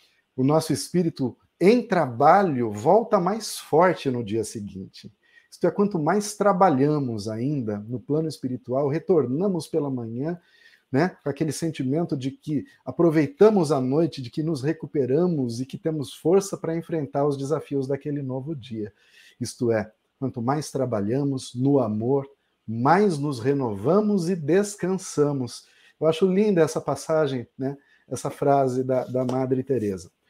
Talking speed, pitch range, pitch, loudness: 140 wpm, 130-170 Hz, 145 Hz, -24 LUFS